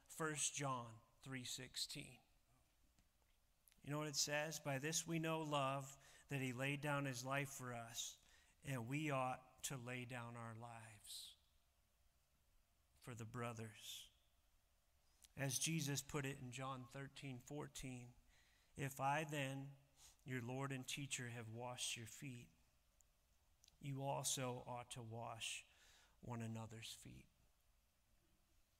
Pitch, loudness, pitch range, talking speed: 125 Hz, -47 LUFS, 100-140 Hz, 120 wpm